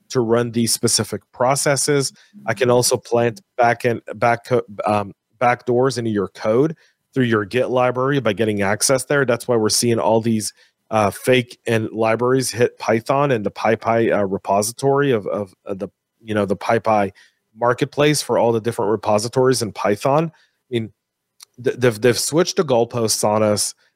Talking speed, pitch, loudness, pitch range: 170 wpm, 115 Hz, -19 LUFS, 110-125 Hz